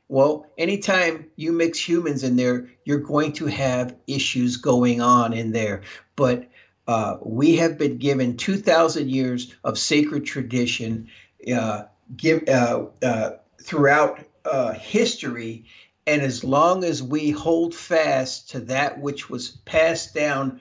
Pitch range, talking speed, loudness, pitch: 125-155 Hz, 130 wpm, -22 LUFS, 135 Hz